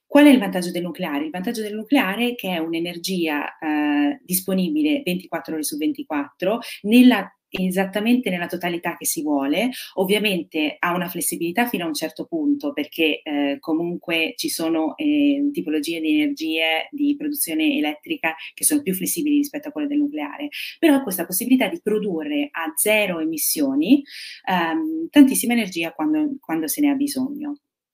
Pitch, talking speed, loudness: 210 Hz, 160 wpm, -21 LUFS